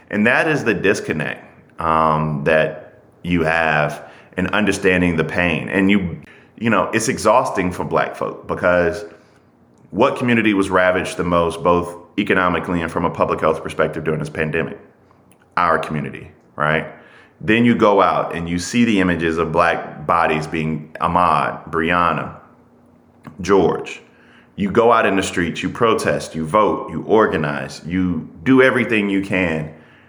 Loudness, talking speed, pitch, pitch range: -18 LUFS, 150 wpm, 85 Hz, 80-95 Hz